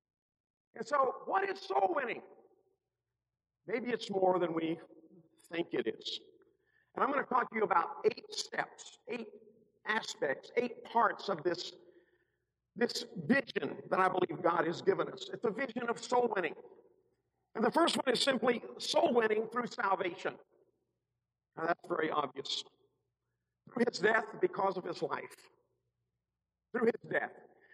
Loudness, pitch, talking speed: -34 LUFS, 235 Hz, 150 wpm